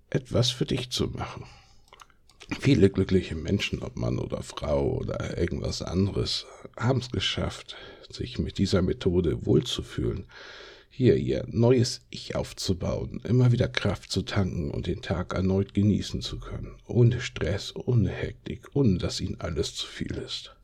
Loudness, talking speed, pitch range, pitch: -27 LUFS, 150 wpm, 95-120 Hz, 100 Hz